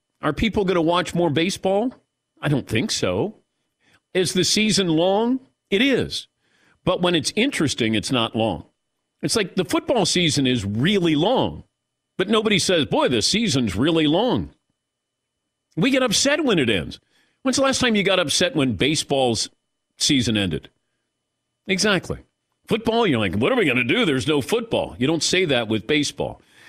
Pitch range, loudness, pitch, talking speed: 155-215 Hz, -20 LUFS, 180 Hz, 170 wpm